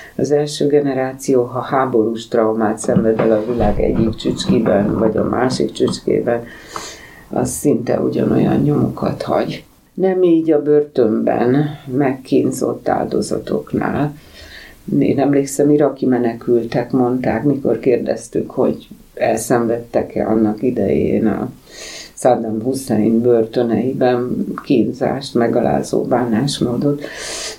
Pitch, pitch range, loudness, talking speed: 125 Hz, 115-140 Hz, -17 LUFS, 100 wpm